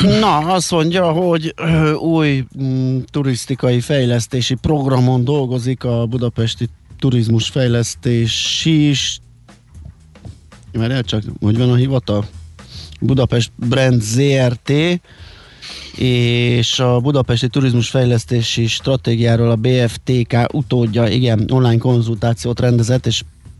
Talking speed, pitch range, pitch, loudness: 100 wpm, 115-130 Hz, 120 Hz, -16 LUFS